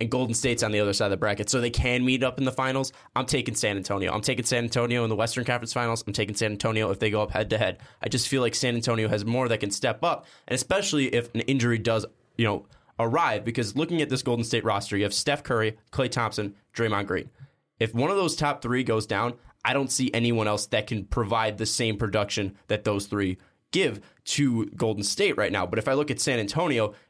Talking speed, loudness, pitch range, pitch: 250 wpm, -26 LUFS, 105-130 Hz, 115 Hz